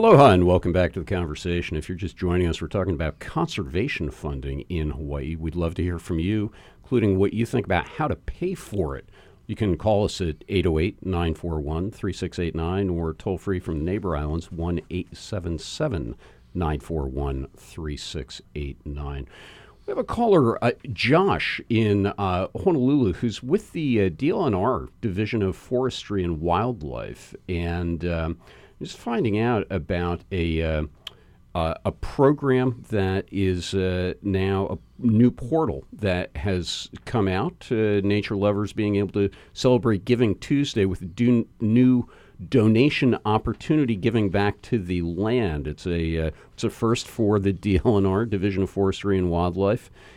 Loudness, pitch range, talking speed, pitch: -24 LUFS, 85-110 Hz, 145 wpm, 95 Hz